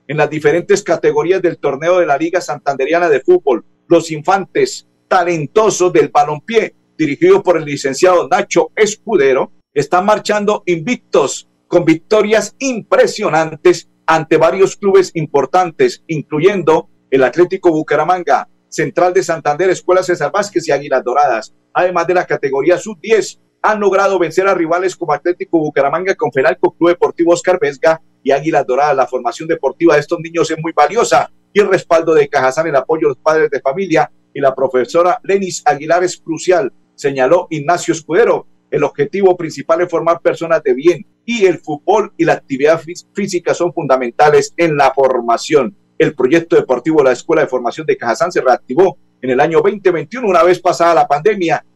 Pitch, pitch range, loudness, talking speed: 170 Hz, 150-190 Hz, -14 LUFS, 160 wpm